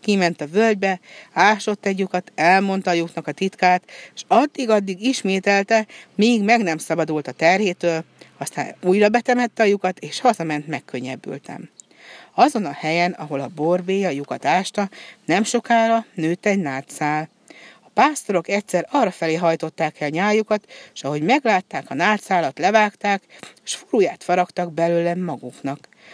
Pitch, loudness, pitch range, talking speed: 185 Hz, -20 LUFS, 160-210 Hz, 140 wpm